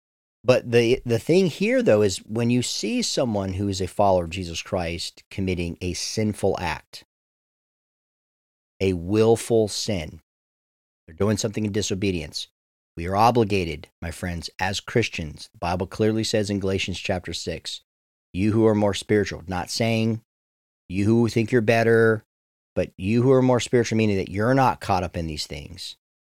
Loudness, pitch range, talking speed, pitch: -23 LUFS, 85-115 Hz, 165 wpm, 100 Hz